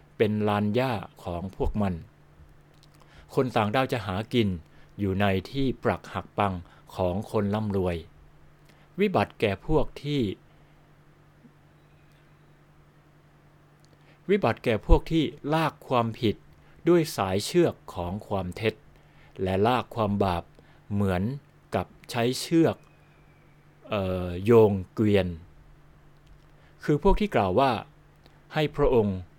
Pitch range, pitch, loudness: 95-135 Hz, 105 Hz, -27 LUFS